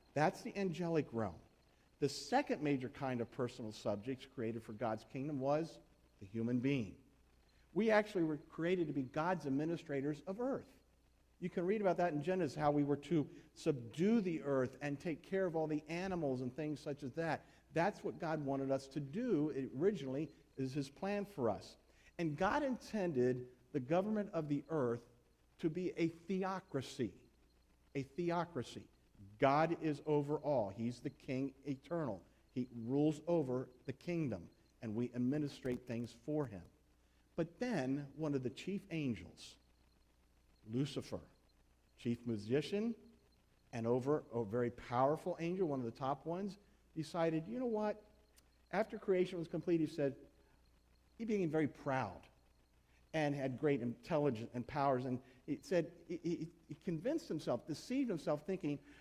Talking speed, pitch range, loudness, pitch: 155 wpm, 125-170 Hz, -40 LUFS, 145 Hz